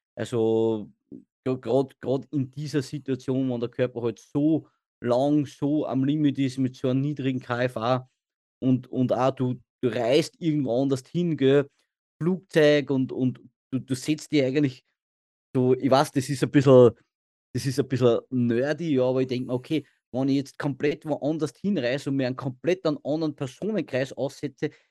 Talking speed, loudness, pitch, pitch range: 170 wpm, -25 LUFS, 135 Hz, 125-145 Hz